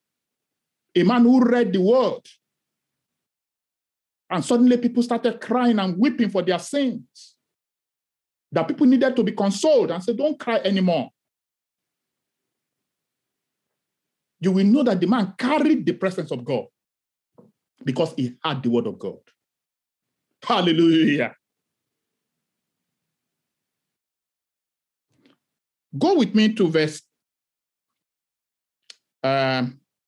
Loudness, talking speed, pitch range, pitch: -21 LUFS, 105 wpm, 165-245 Hz, 205 Hz